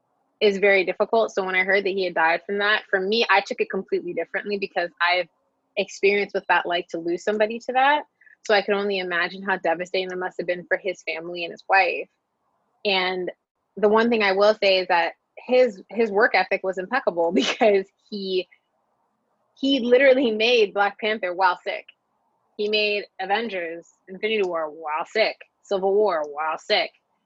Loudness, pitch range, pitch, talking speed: -22 LUFS, 180-215 Hz, 195 Hz, 185 wpm